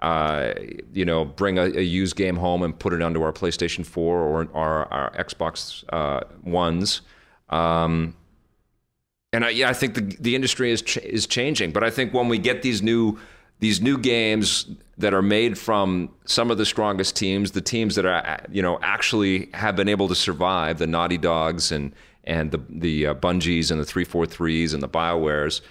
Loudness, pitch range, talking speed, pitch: -23 LUFS, 80-105 Hz, 190 wpm, 90 Hz